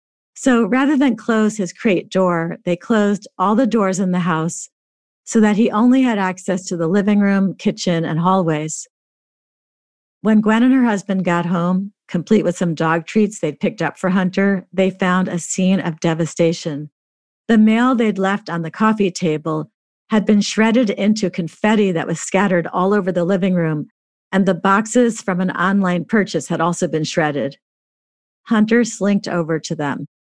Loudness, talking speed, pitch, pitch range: -17 LUFS, 175 wpm, 190 Hz, 170-215 Hz